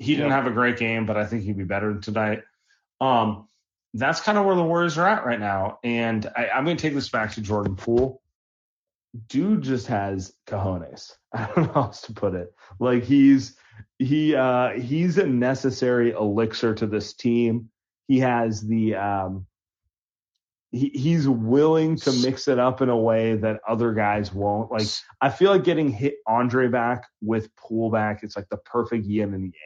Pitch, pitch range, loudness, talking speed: 115 Hz, 105-130 Hz, -23 LUFS, 190 wpm